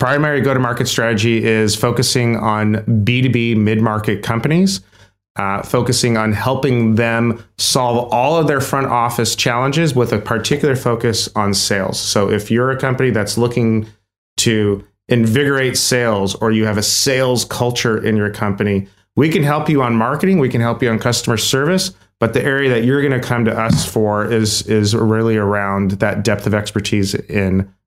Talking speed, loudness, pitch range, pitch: 175 wpm, -15 LUFS, 105-125 Hz, 115 Hz